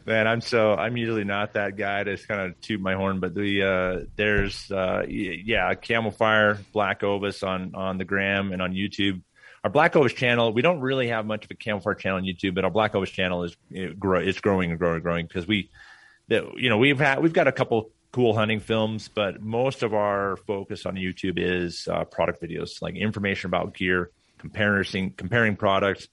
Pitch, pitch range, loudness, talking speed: 100 Hz, 95-110 Hz, -25 LUFS, 205 wpm